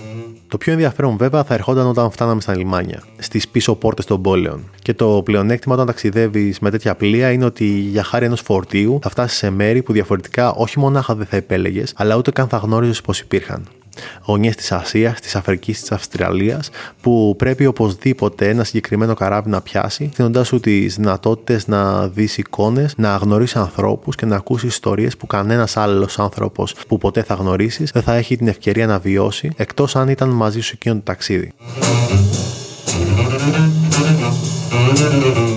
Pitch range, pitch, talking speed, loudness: 100-125 Hz, 110 Hz, 165 wpm, -16 LUFS